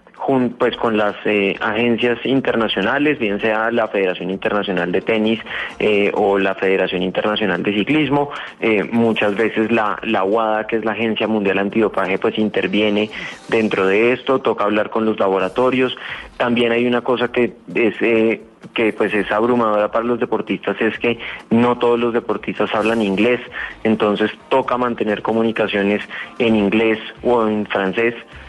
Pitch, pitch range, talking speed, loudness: 110 Hz, 105-120 Hz, 155 wpm, -18 LUFS